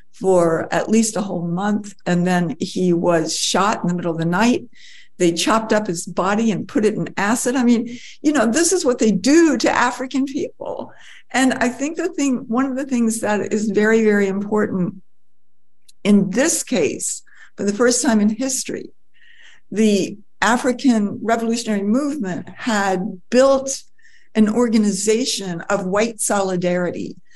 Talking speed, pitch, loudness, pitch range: 160 wpm, 220 Hz, -19 LUFS, 190-255 Hz